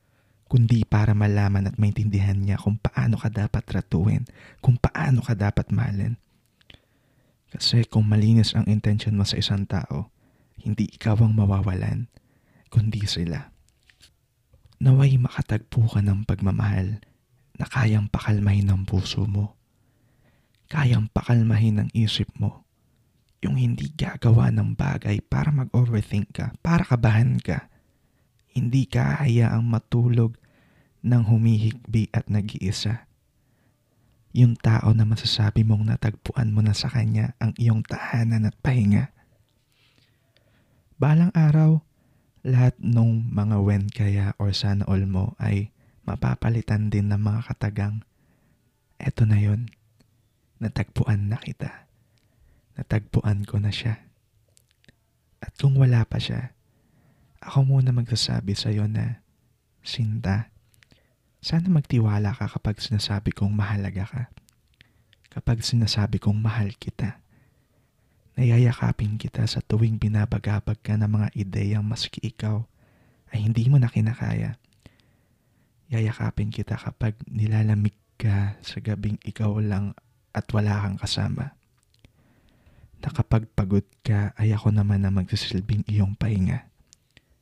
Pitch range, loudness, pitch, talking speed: 105-120 Hz, -23 LUFS, 110 Hz, 115 wpm